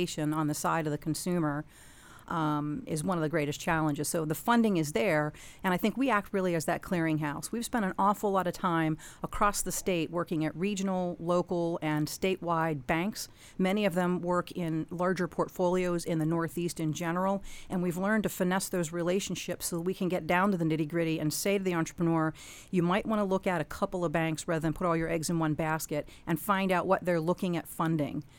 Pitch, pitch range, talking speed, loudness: 175 Hz, 160-185 Hz, 220 wpm, -31 LUFS